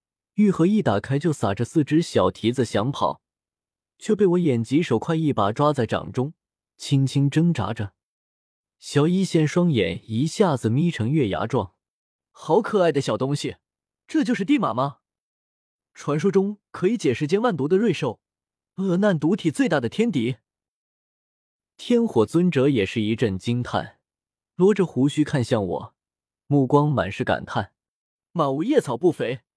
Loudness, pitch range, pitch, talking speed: -22 LUFS, 115-175 Hz, 140 Hz, 225 characters per minute